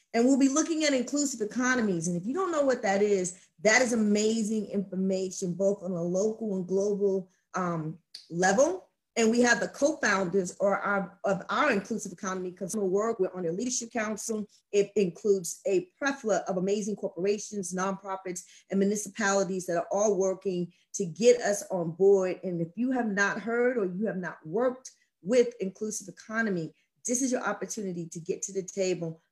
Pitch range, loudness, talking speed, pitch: 185-225 Hz, -28 LUFS, 175 wpm, 200 Hz